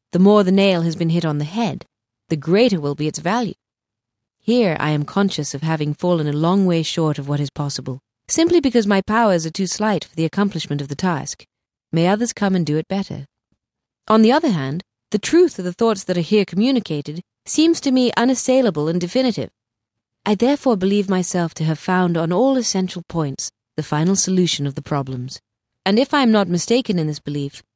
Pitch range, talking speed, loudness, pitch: 150-215 Hz, 210 wpm, -19 LUFS, 175 Hz